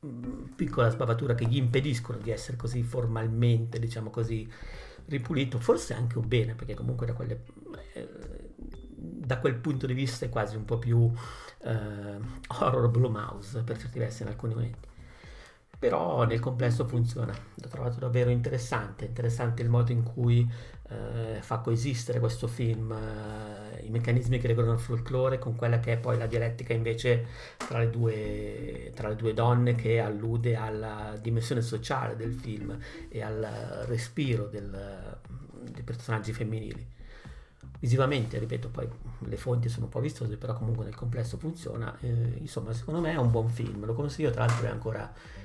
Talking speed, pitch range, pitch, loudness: 160 wpm, 110-120 Hz, 120 Hz, -30 LUFS